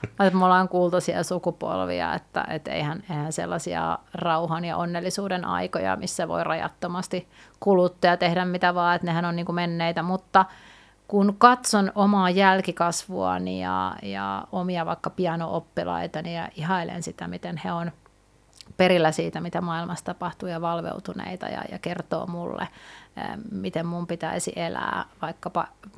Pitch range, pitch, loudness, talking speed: 165-185 Hz, 175 Hz, -25 LUFS, 140 wpm